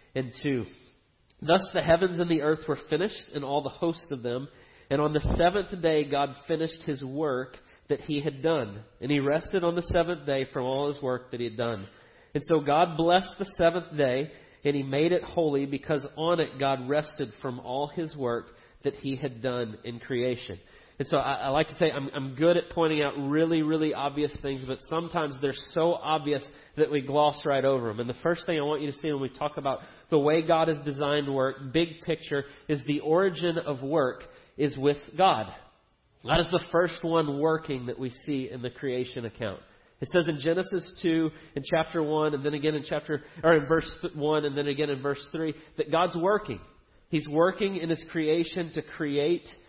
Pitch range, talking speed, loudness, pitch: 135-165 Hz, 210 wpm, -28 LUFS, 150 Hz